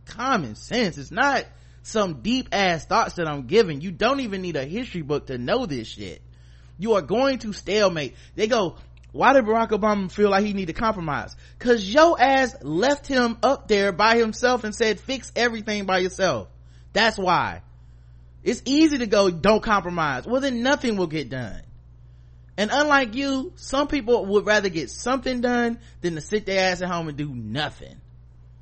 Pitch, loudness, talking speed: 195 Hz, -22 LUFS, 185 wpm